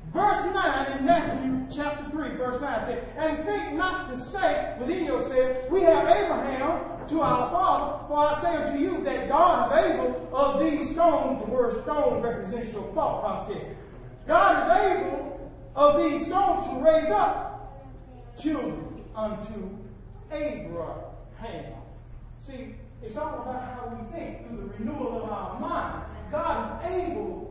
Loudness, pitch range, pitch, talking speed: -26 LUFS, 265-350 Hz, 300 Hz, 155 wpm